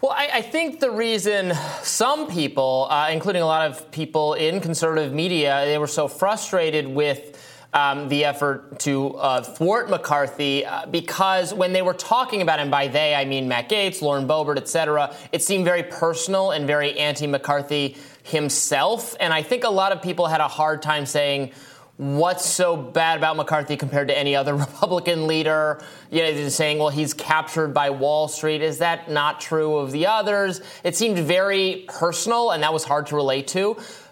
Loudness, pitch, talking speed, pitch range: -21 LUFS, 155 Hz, 190 wpm, 145-180 Hz